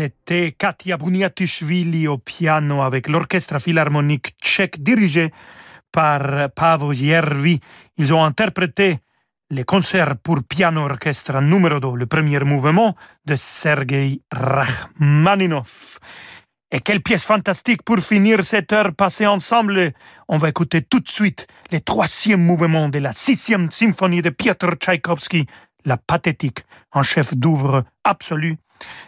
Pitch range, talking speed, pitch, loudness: 145-190 Hz, 125 wpm, 165 Hz, -18 LUFS